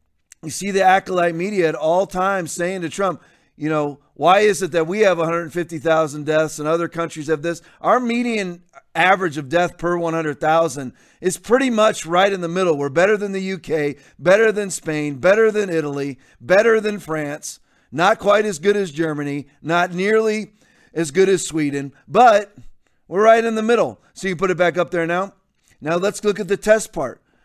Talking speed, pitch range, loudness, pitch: 190 wpm, 155-200 Hz, -19 LUFS, 175 Hz